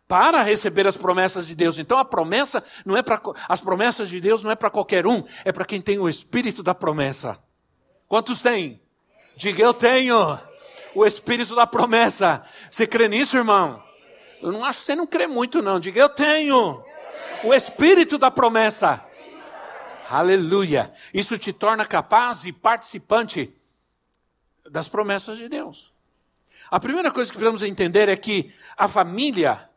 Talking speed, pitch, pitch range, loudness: 160 wpm, 220 Hz, 190-245 Hz, -20 LUFS